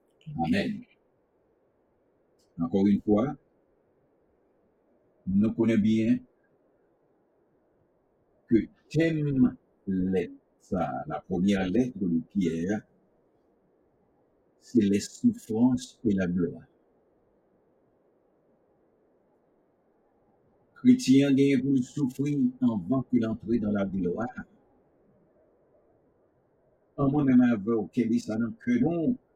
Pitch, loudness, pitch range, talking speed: 120 Hz, -27 LUFS, 105-145 Hz, 80 wpm